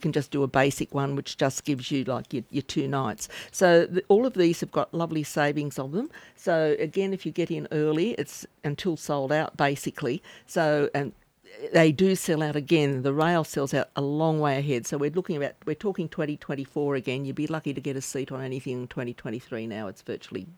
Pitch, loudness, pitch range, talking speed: 150 Hz, -27 LUFS, 140-165 Hz, 220 wpm